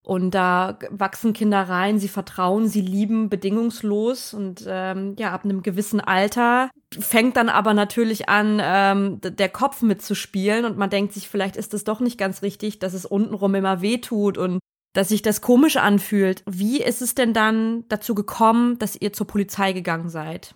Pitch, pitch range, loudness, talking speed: 205 Hz, 195-220 Hz, -21 LUFS, 185 wpm